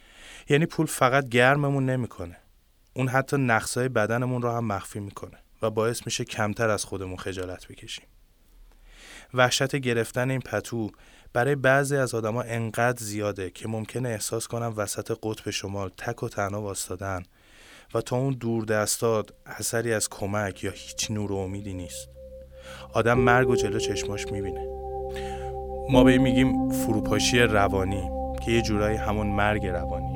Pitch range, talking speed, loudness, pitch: 95-125 Hz, 145 wpm, -26 LUFS, 105 Hz